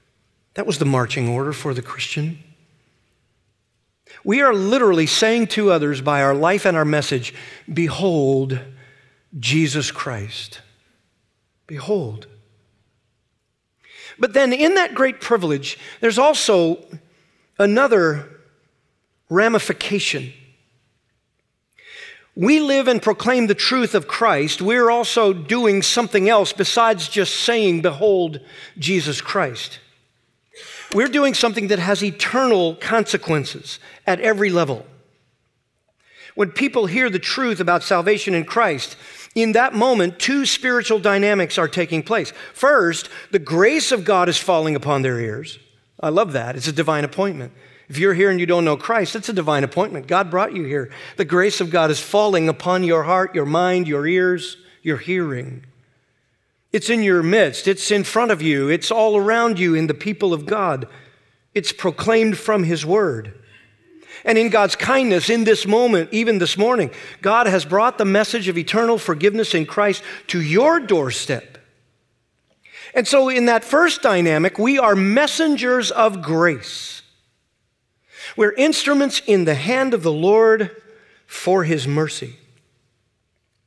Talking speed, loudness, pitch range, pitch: 140 wpm, -18 LUFS, 145-220 Hz, 180 Hz